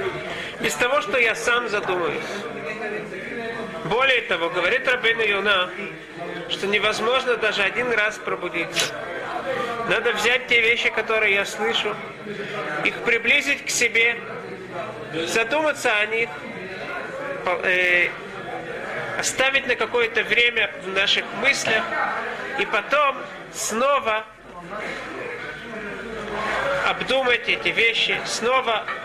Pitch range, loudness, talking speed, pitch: 210-245 Hz, -21 LUFS, 95 wpm, 225 Hz